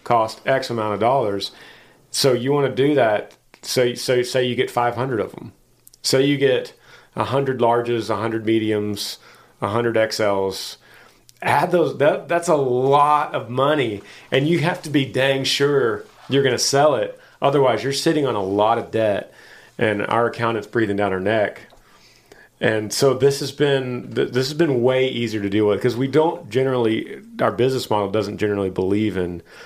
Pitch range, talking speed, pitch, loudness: 110-135 Hz, 180 wpm, 125 Hz, -20 LUFS